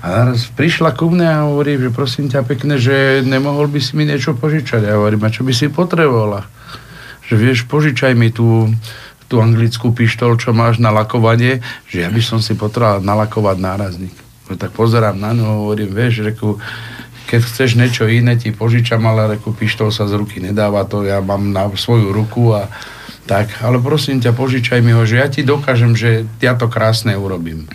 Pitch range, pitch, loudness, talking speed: 105-130 Hz, 115 Hz, -14 LUFS, 190 wpm